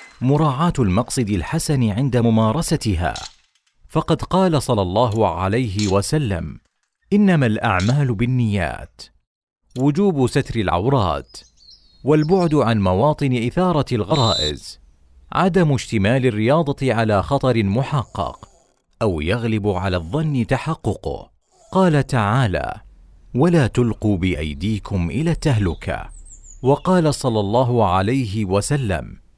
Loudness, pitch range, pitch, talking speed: -19 LUFS, 100-145 Hz, 120 Hz, 90 wpm